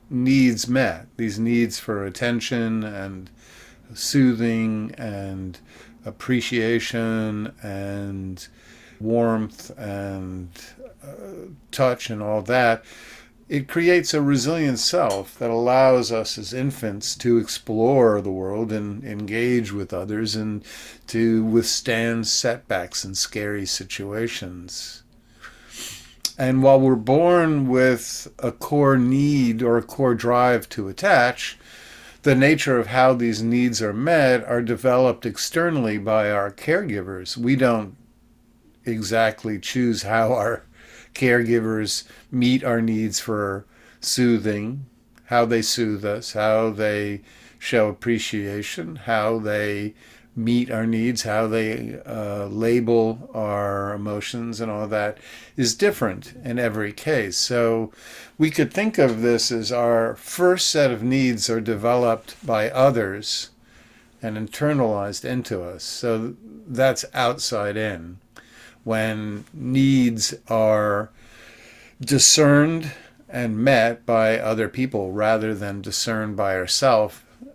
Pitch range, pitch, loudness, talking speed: 105-125 Hz, 115 Hz, -21 LUFS, 115 wpm